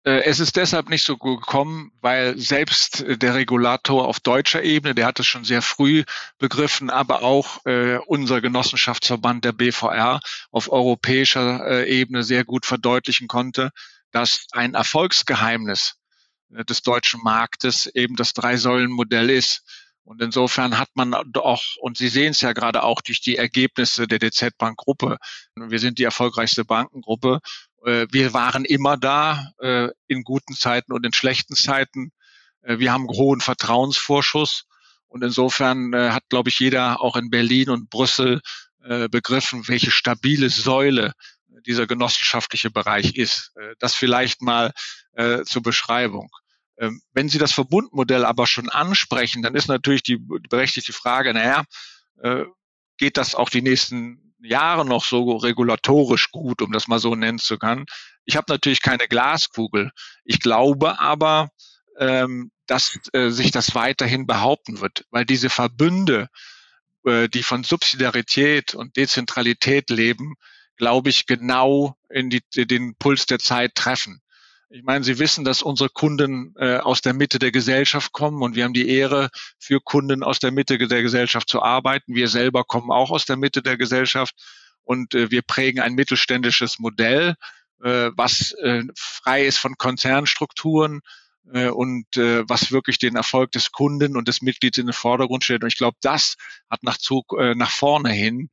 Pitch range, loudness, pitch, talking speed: 120-135 Hz, -19 LUFS, 125 Hz, 150 wpm